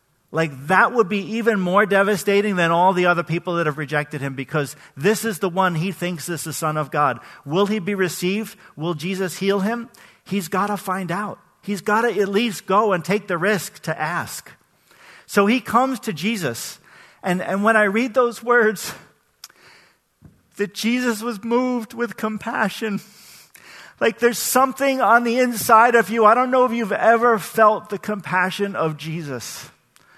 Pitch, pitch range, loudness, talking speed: 200 Hz, 175-225 Hz, -20 LUFS, 180 wpm